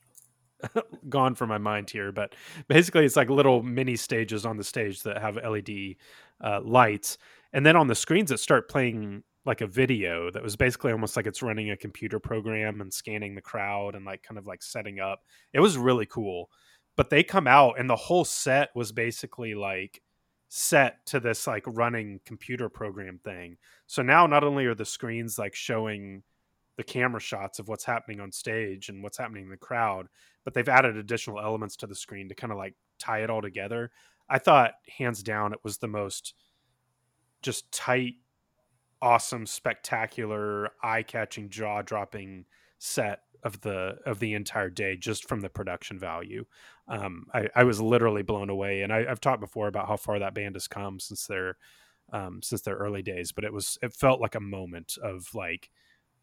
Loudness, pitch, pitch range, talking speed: -27 LUFS, 110 Hz, 100-120 Hz, 190 wpm